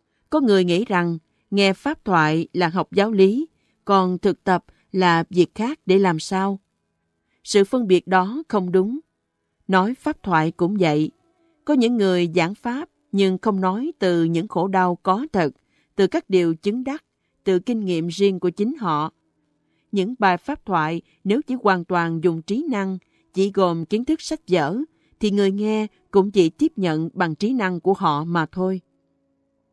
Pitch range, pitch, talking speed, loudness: 175-215 Hz, 190 Hz, 180 wpm, -21 LUFS